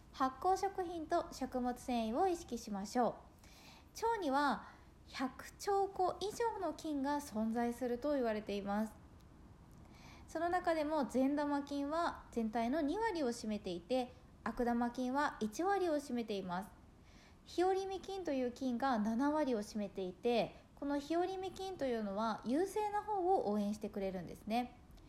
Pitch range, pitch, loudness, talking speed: 230-340 Hz, 270 Hz, -38 LUFS, 270 characters per minute